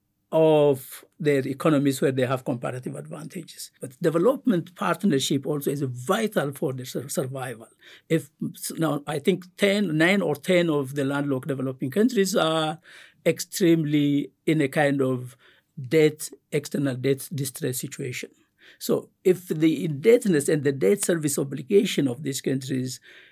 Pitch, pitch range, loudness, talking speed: 150 Hz, 135-170 Hz, -24 LUFS, 135 wpm